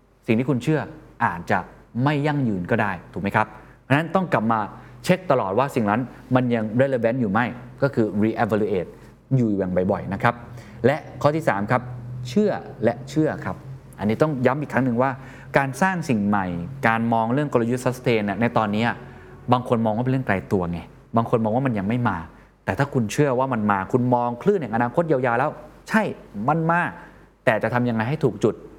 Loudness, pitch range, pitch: -23 LUFS, 110-135 Hz, 125 Hz